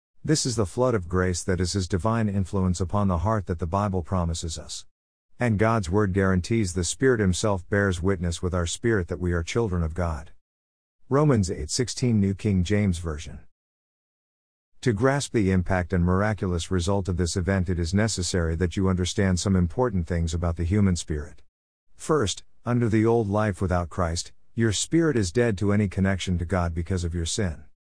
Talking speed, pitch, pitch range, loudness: 185 wpm, 95 Hz, 85-105 Hz, -25 LUFS